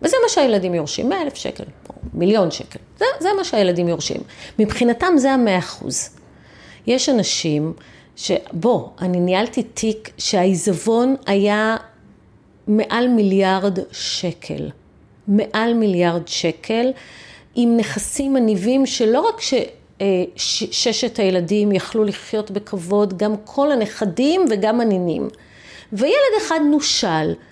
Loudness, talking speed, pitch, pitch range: -19 LUFS, 115 wpm, 215 Hz, 185-245 Hz